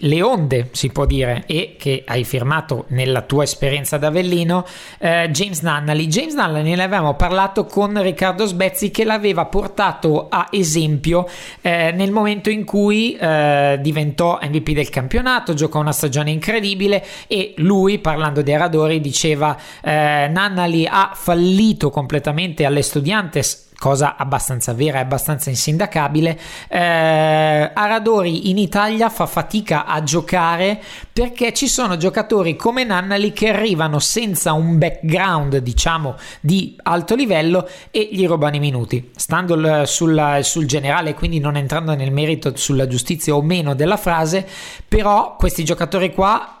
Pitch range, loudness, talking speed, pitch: 150-195 Hz, -17 LUFS, 140 wpm, 165 Hz